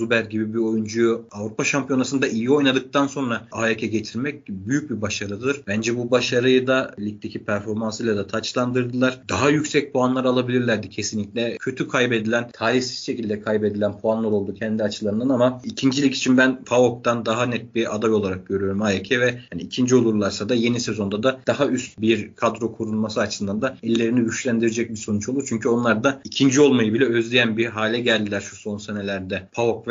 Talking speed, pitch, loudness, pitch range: 165 wpm, 115 Hz, -22 LUFS, 110-125 Hz